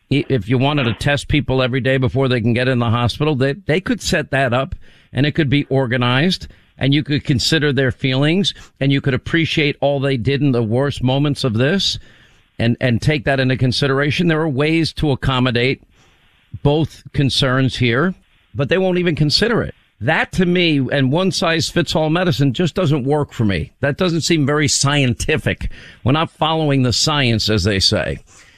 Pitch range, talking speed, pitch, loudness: 125-150 Hz, 195 wpm, 140 Hz, -17 LUFS